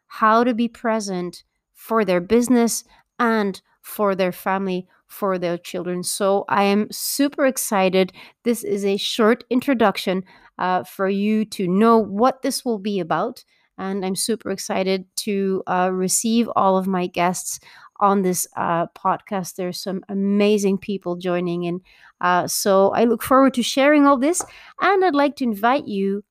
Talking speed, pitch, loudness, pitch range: 160 wpm, 200 Hz, -20 LUFS, 185-230 Hz